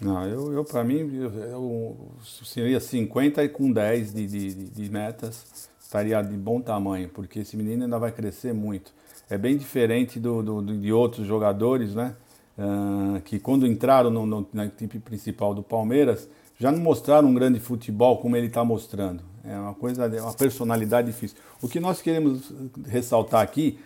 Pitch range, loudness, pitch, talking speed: 105-125 Hz, -25 LUFS, 115 Hz, 175 wpm